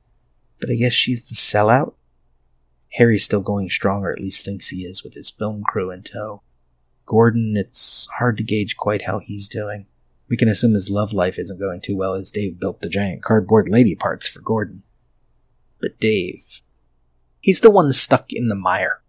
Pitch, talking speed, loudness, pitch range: 105 Hz, 190 wpm, -18 LUFS, 95-115 Hz